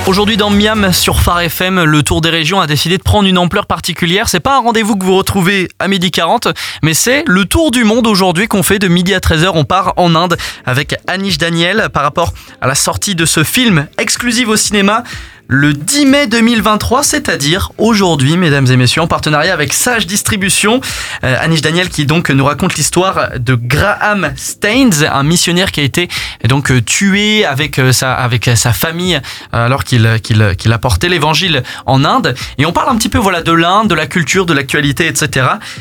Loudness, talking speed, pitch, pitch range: -11 LUFS, 195 wpm, 175 Hz, 145-200 Hz